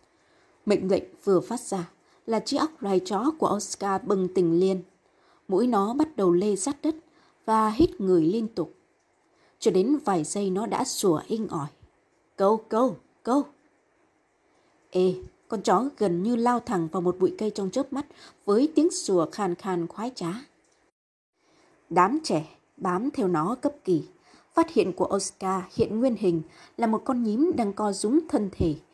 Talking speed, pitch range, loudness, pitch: 170 wpm, 190-290 Hz, -26 LUFS, 215 Hz